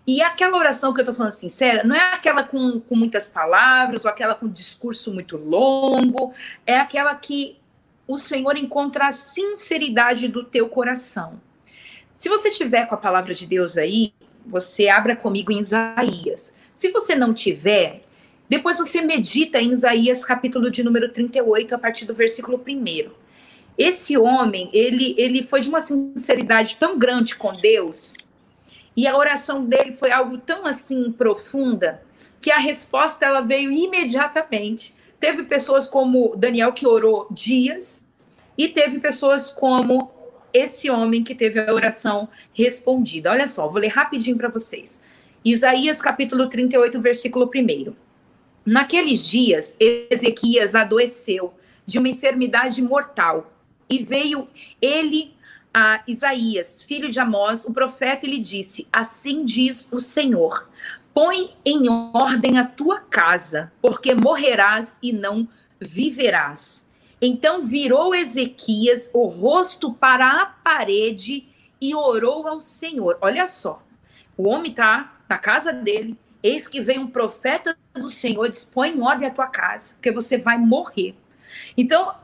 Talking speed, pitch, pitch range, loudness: 140 wpm, 255 Hz, 230-285 Hz, -19 LUFS